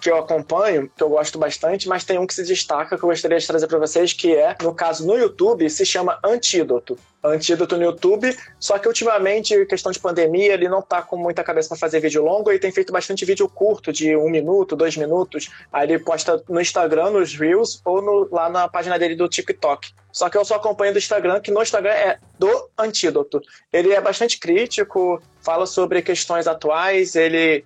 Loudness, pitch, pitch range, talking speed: -19 LUFS, 180 Hz, 165-210 Hz, 210 wpm